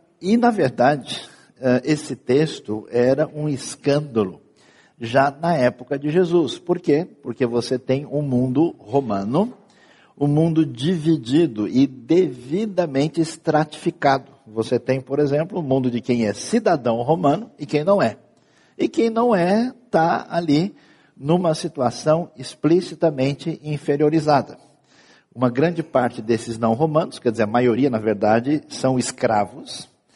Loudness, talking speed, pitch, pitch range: -20 LUFS, 130 wpm, 145 Hz, 125-165 Hz